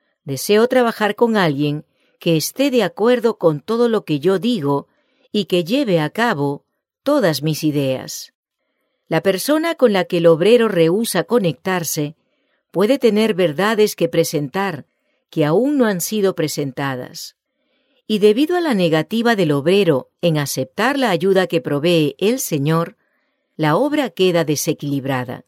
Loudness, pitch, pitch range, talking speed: -17 LUFS, 185 Hz, 155-235 Hz, 145 wpm